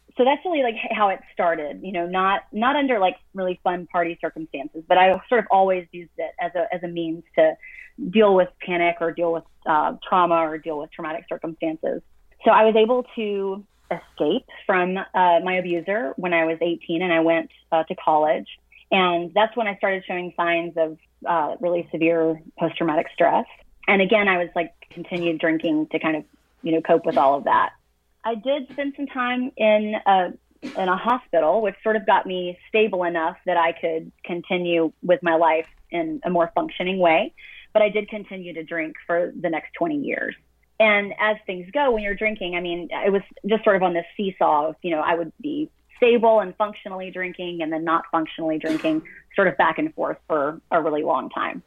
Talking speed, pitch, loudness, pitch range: 205 wpm, 180 Hz, -22 LUFS, 165-215 Hz